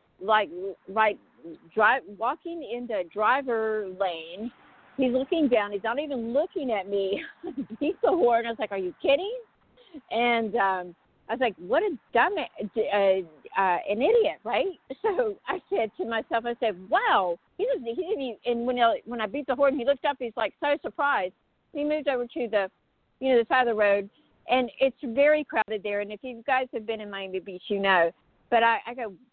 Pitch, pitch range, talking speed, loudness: 235 Hz, 210-285 Hz, 205 wpm, -27 LUFS